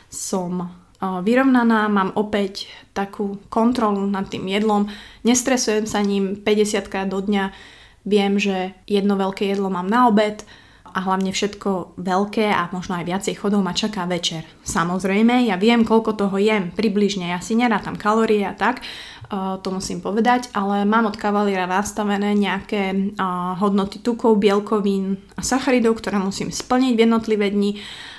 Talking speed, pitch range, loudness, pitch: 145 wpm, 190-220 Hz, -20 LUFS, 205 Hz